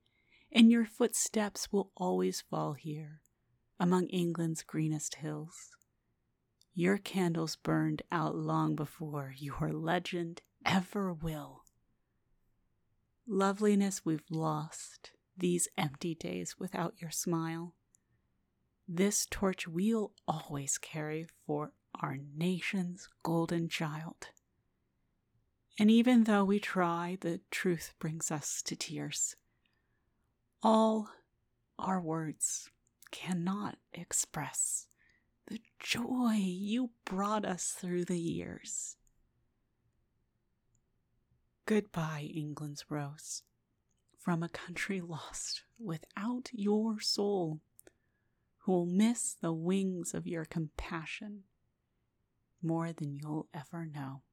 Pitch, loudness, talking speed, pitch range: 170 Hz, -34 LUFS, 95 wpm, 155-195 Hz